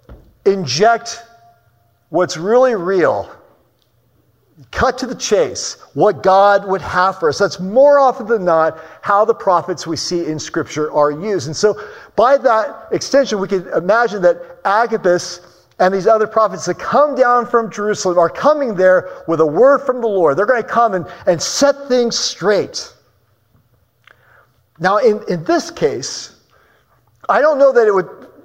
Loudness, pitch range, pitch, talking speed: -15 LUFS, 175-245 Hz, 200 Hz, 160 wpm